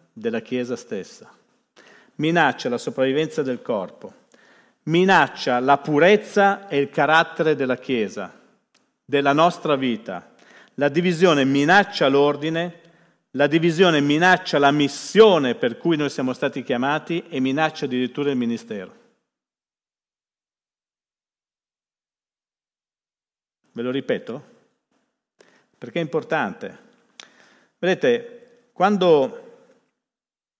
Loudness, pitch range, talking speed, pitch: -20 LUFS, 140-175 Hz, 90 wpm, 155 Hz